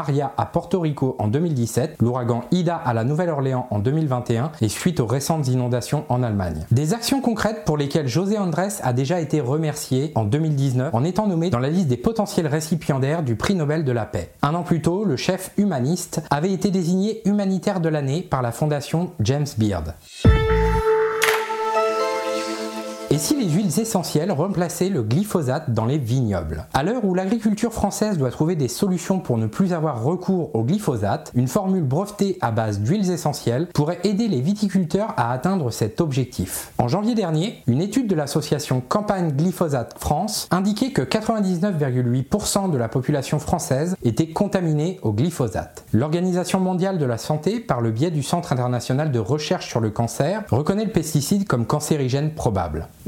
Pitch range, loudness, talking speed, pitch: 125-190 Hz, -22 LUFS, 170 wpm, 155 Hz